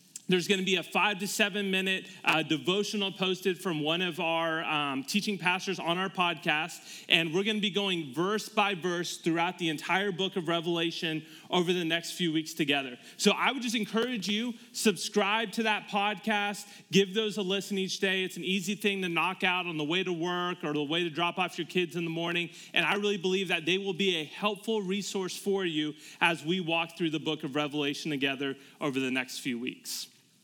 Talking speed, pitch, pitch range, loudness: 215 wpm, 180 Hz, 165-200 Hz, -29 LUFS